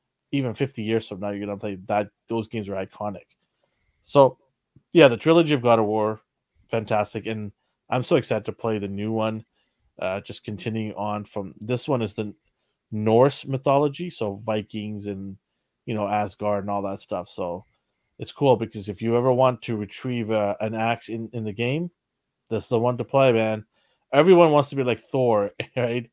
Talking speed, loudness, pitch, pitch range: 190 wpm, -24 LUFS, 110 Hz, 105-125 Hz